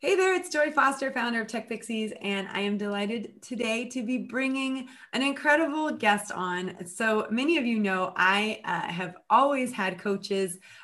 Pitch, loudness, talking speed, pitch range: 225 Hz, -27 LUFS, 175 wpm, 200-265 Hz